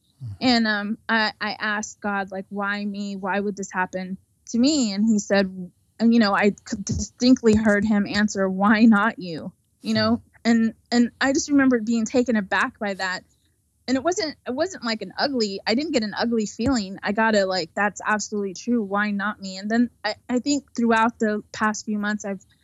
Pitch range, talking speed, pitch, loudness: 200-235 Hz, 200 wpm, 215 Hz, -22 LUFS